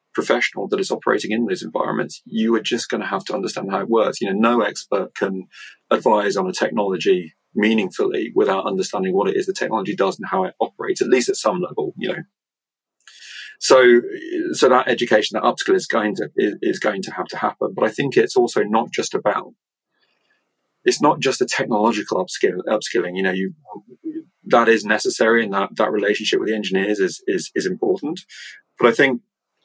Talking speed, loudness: 200 wpm, -20 LUFS